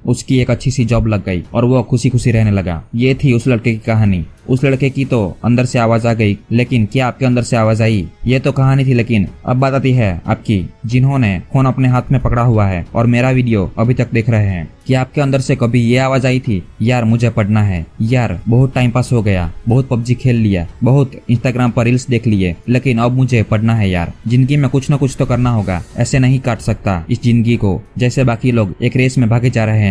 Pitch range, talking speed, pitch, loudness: 110-130 Hz, 245 wpm, 120 Hz, -14 LUFS